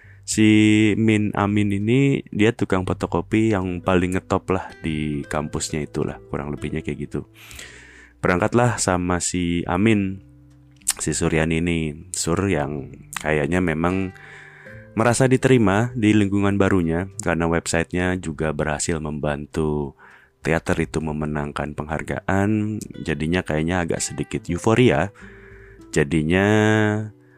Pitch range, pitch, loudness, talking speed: 80-105 Hz, 90 Hz, -21 LUFS, 105 wpm